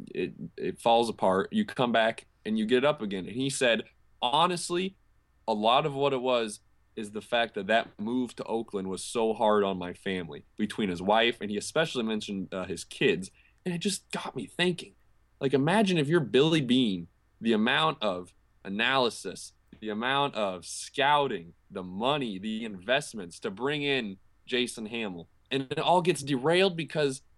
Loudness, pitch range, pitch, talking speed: -28 LUFS, 105-155 Hz, 125 Hz, 180 wpm